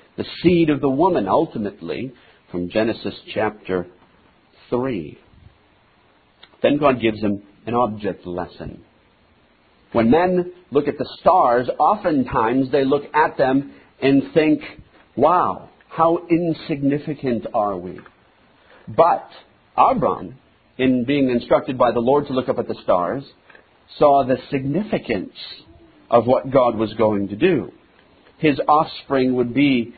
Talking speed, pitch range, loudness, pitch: 125 wpm, 105-145 Hz, -19 LUFS, 130 Hz